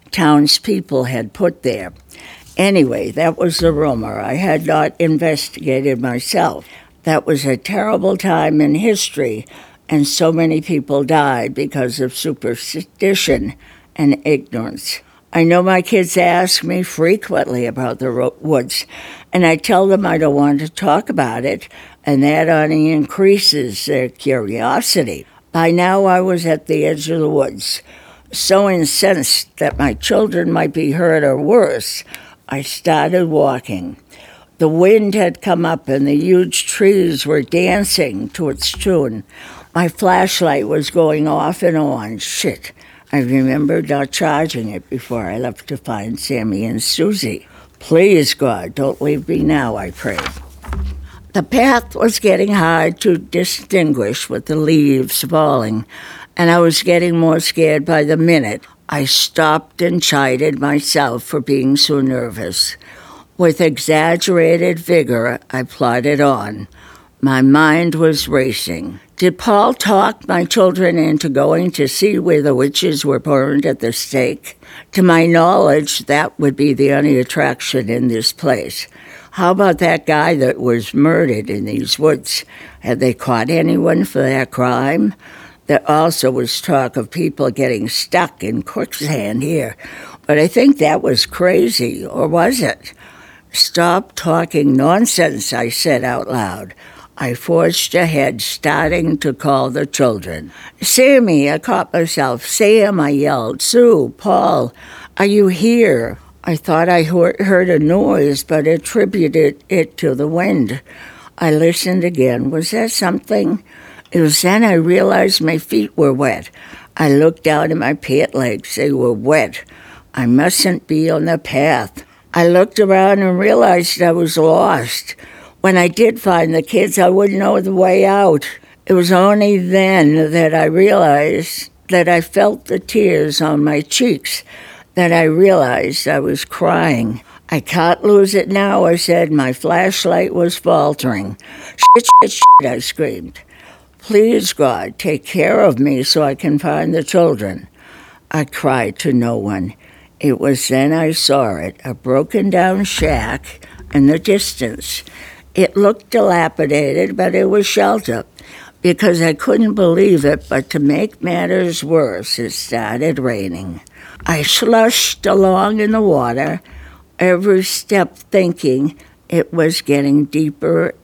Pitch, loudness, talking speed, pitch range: 160 Hz, -14 LUFS, 150 wpm, 140-180 Hz